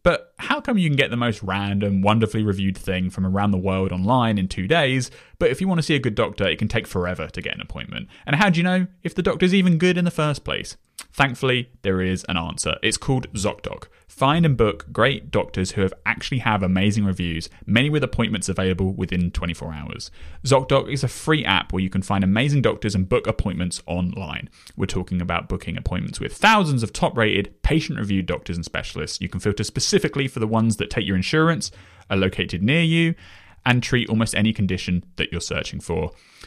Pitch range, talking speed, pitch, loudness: 95-135 Hz, 215 wpm, 105 Hz, -22 LUFS